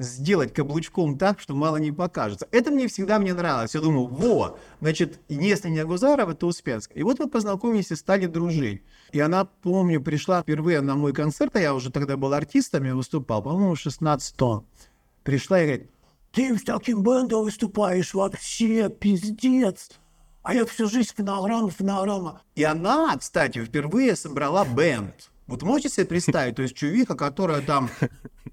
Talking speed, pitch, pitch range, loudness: 165 wpm, 175 Hz, 145-210 Hz, -24 LUFS